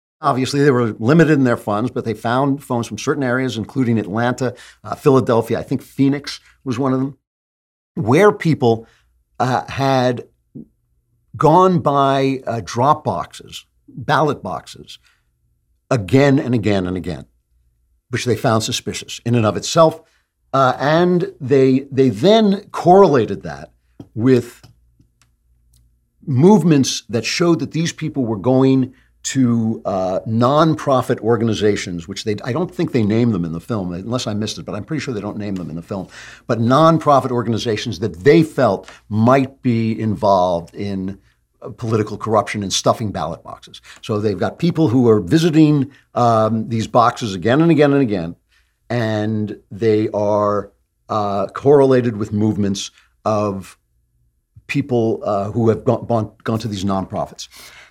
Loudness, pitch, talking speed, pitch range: -17 LUFS, 115 Hz, 145 wpm, 105-135 Hz